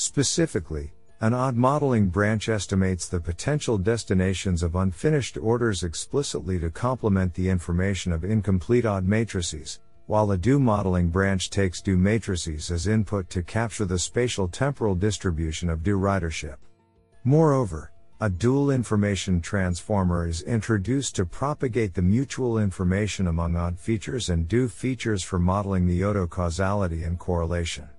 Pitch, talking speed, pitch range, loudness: 100 Hz, 140 wpm, 90-115 Hz, -25 LUFS